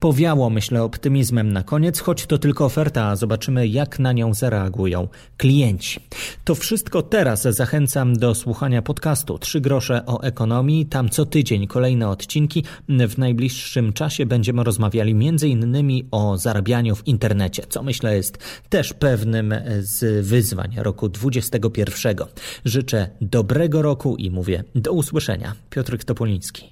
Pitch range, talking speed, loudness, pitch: 110-140 Hz, 135 wpm, -20 LUFS, 120 Hz